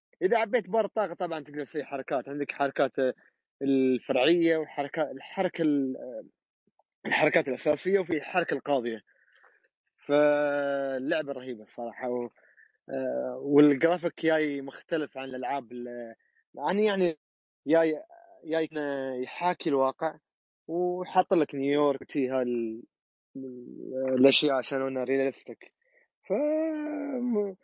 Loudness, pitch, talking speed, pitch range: -28 LUFS, 145 Hz, 90 wpm, 130-175 Hz